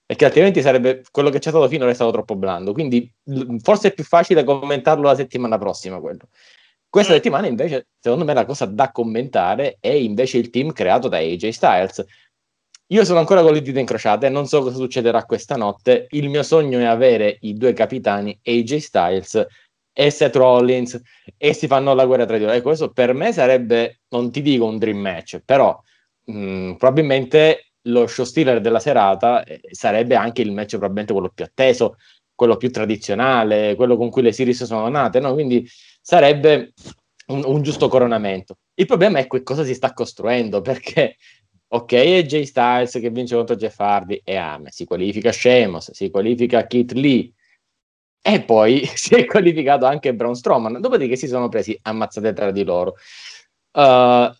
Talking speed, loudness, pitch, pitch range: 180 wpm, -17 LUFS, 125 Hz, 115-145 Hz